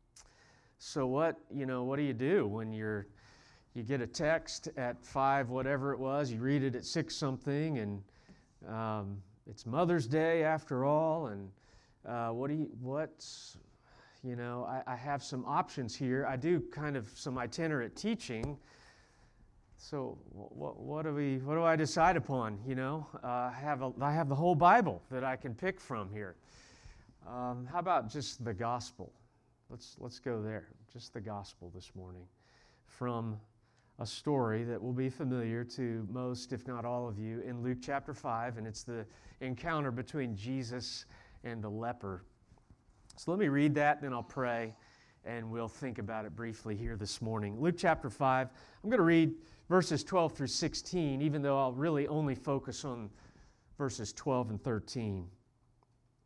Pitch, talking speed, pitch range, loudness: 125 Hz, 175 wpm, 115-145 Hz, -35 LUFS